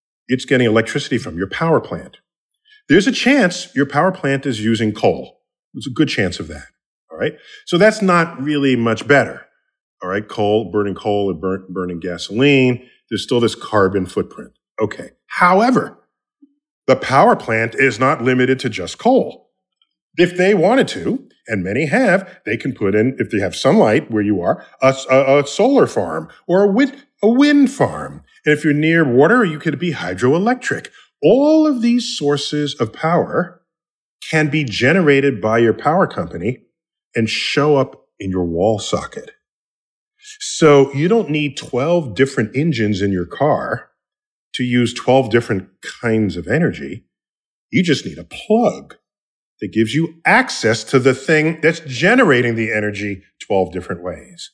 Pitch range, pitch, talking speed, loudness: 110-175 Hz, 135 Hz, 165 wpm, -16 LUFS